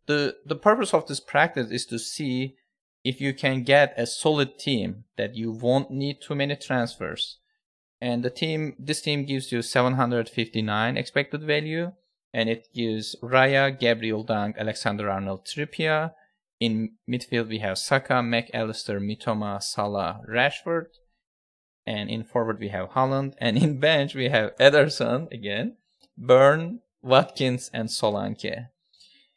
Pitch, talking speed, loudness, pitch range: 125 Hz, 140 wpm, -25 LUFS, 115-145 Hz